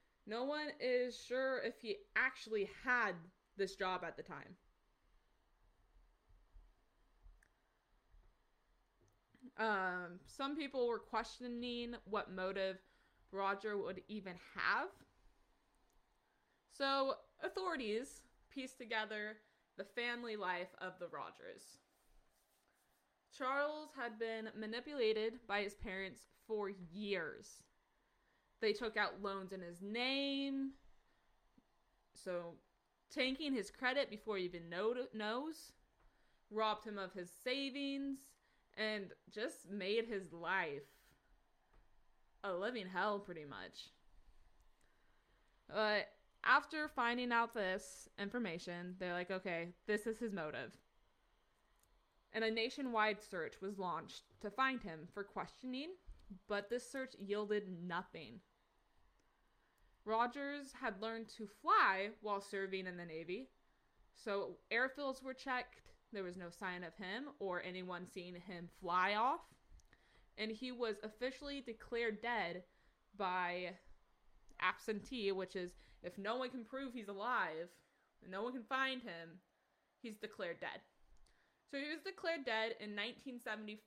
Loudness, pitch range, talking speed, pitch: -42 LUFS, 190-250 Hz, 115 wpm, 215 Hz